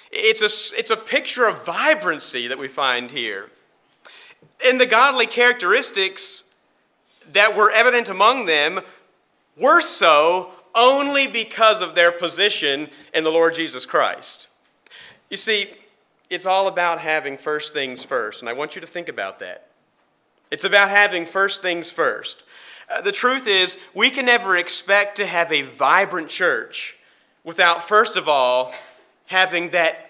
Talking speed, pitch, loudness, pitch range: 150 wpm, 195 Hz, -18 LUFS, 170-230 Hz